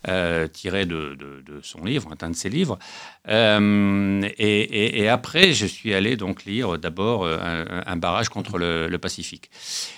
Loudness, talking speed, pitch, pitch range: -22 LUFS, 175 wpm, 95 Hz, 85-105 Hz